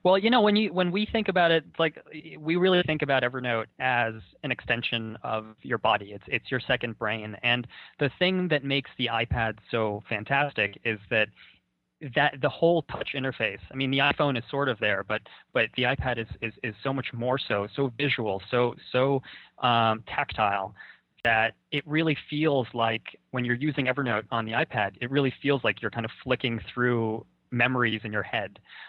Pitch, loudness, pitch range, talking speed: 125 Hz, -27 LUFS, 115-145 Hz, 195 wpm